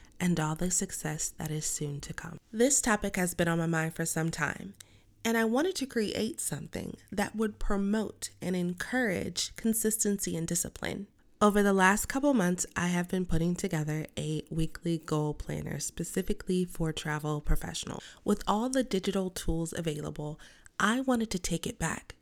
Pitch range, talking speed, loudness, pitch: 165-210 Hz, 170 wpm, -31 LUFS, 180 Hz